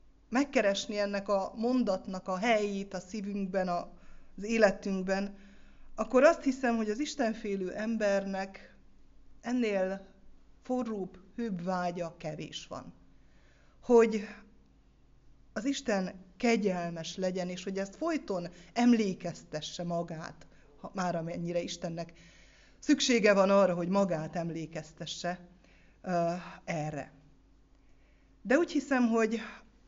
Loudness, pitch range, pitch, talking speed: -31 LUFS, 175-225 Hz, 195 Hz, 100 wpm